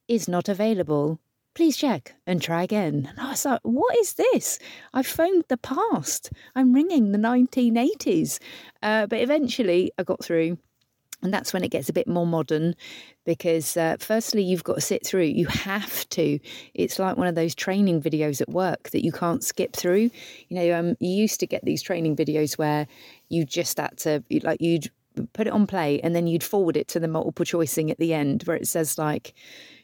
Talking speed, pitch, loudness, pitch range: 200 wpm, 180 Hz, -24 LUFS, 160-230 Hz